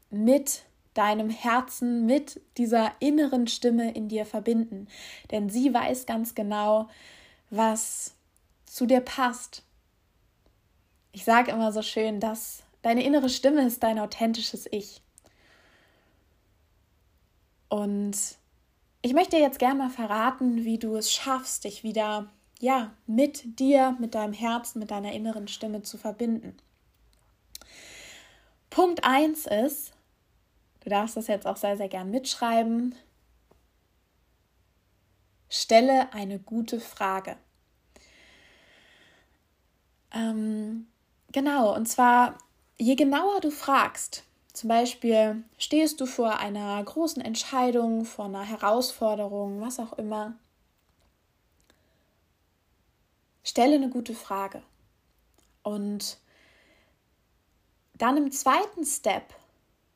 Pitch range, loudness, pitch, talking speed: 205-255 Hz, -27 LUFS, 225 Hz, 105 wpm